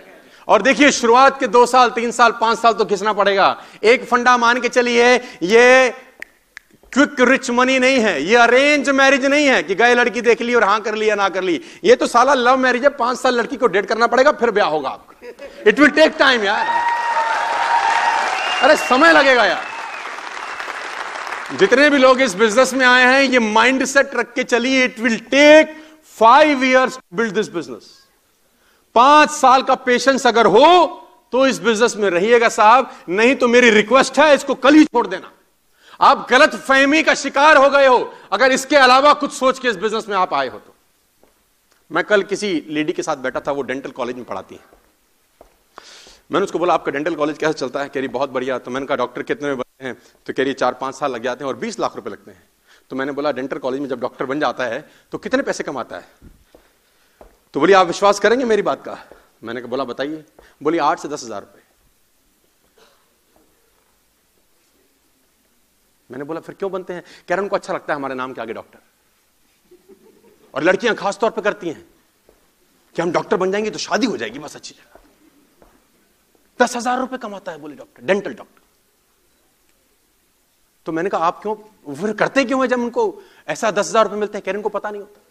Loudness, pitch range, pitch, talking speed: -15 LUFS, 195-270 Hz, 240 Hz, 200 wpm